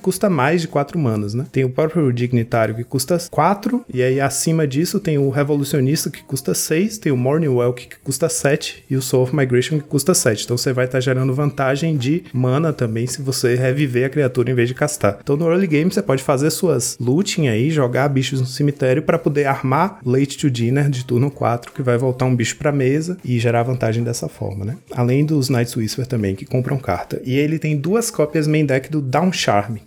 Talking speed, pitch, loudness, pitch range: 225 wpm, 135 Hz, -18 LUFS, 125-155 Hz